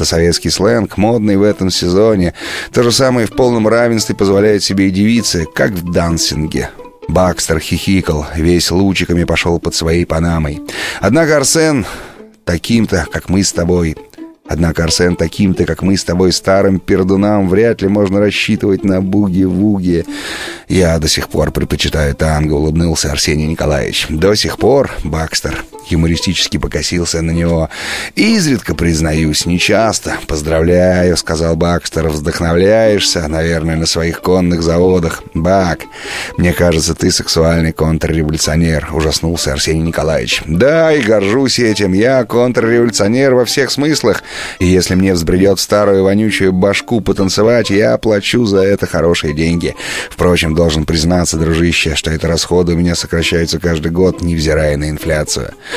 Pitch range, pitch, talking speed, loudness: 80-100 Hz, 85 Hz, 135 wpm, -12 LUFS